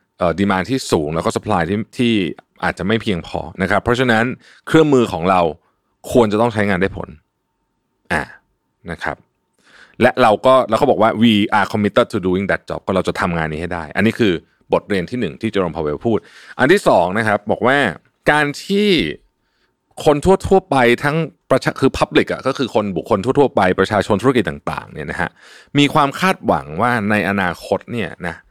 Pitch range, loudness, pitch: 95-130 Hz, -17 LUFS, 110 Hz